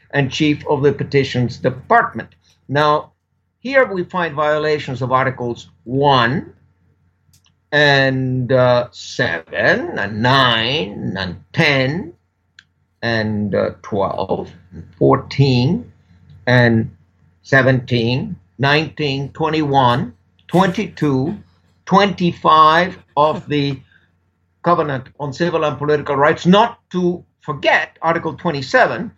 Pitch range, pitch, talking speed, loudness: 120-155 Hz, 140 Hz, 95 wpm, -16 LUFS